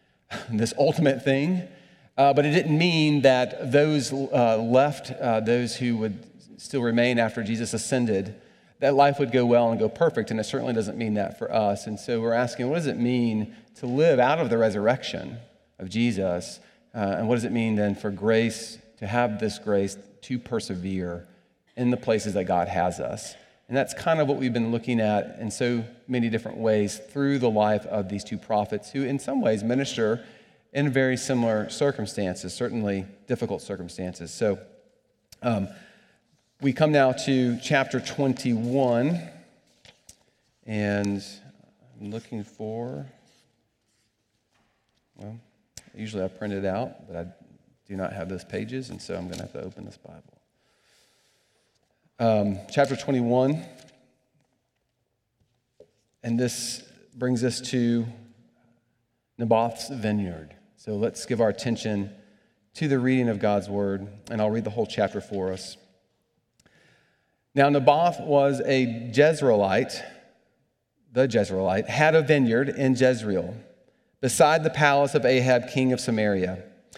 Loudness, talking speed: -25 LUFS, 150 wpm